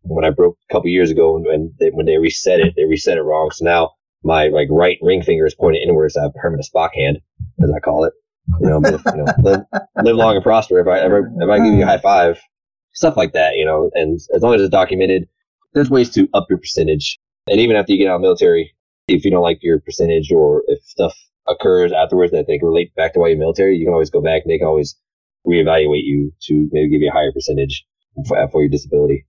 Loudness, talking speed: -15 LUFS, 260 wpm